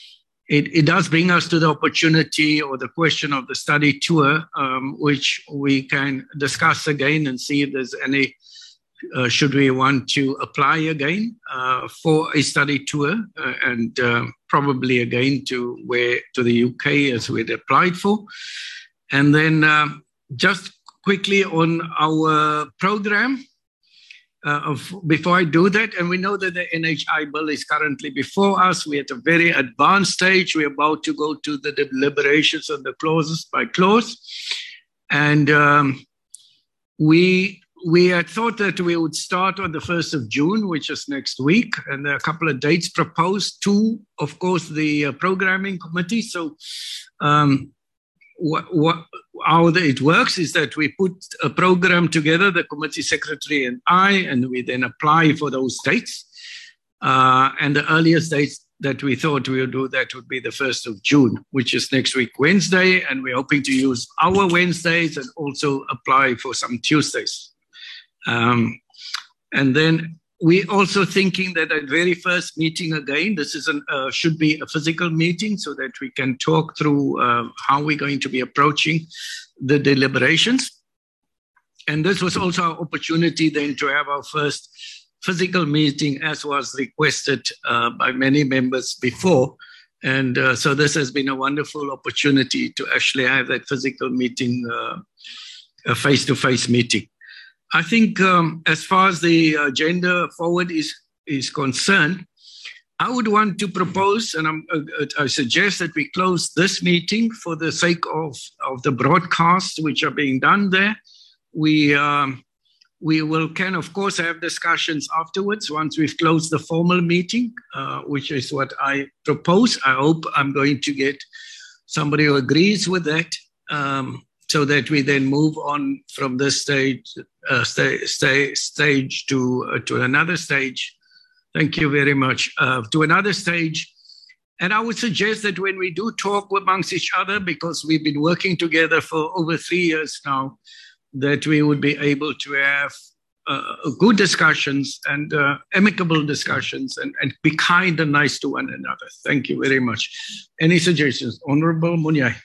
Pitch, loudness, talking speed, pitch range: 155 Hz, -19 LUFS, 165 wpm, 140-180 Hz